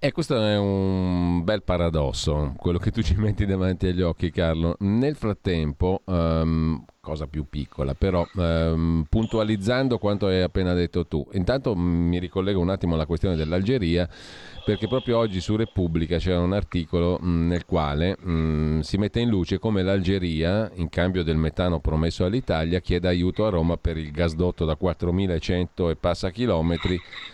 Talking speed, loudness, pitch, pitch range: 165 wpm, -24 LUFS, 90 Hz, 85-95 Hz